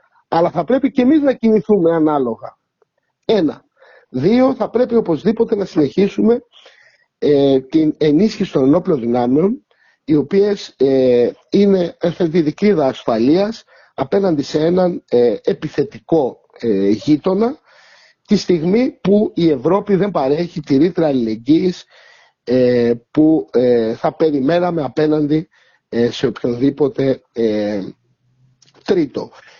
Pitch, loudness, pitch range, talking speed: 160 Hz, -16 LUFS, 135-200 Hz, 110 wpm